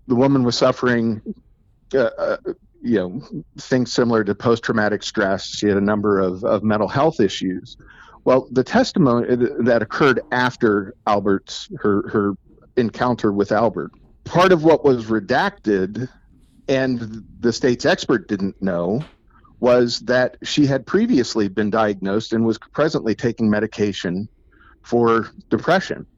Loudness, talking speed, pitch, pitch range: -19 LUFS, 135 wpm, 120 Hz, 105-130 Hz